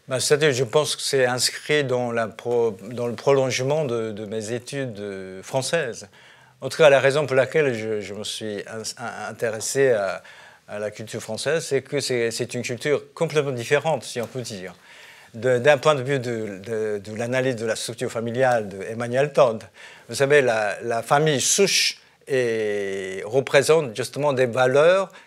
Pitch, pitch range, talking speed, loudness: 125 Hz, 110-140 Hz, 175 wpm, -22 LUFS